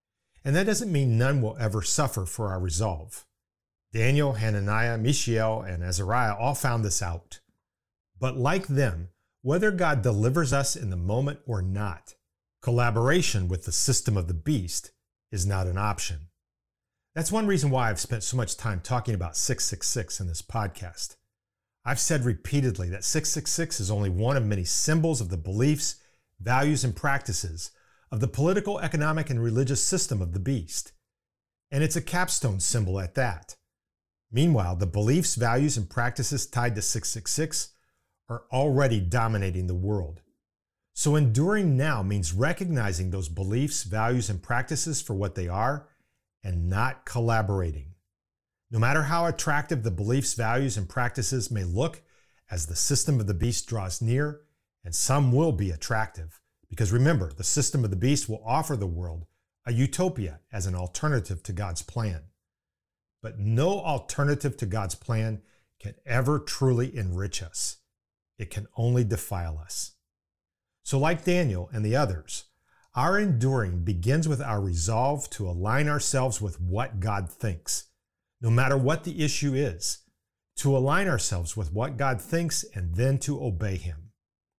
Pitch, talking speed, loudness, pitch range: 115 Hz, 155 wpm, -27 LUFS, 95-135 Hz